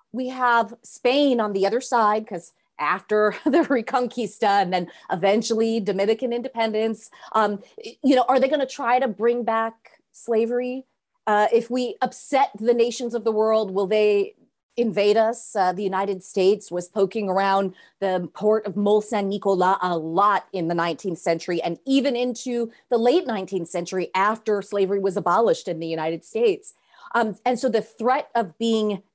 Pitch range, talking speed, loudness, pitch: 195-240 Hz, 165 wpm, -22 LUFS, 215 Hz